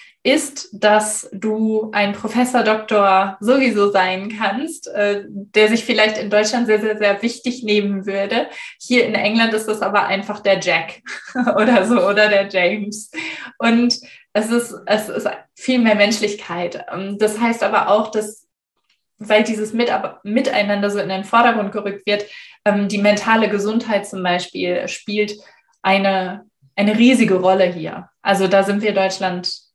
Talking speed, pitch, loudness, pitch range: 145 wpm, 210 Hz, -17 LUFS, 195-230 Hz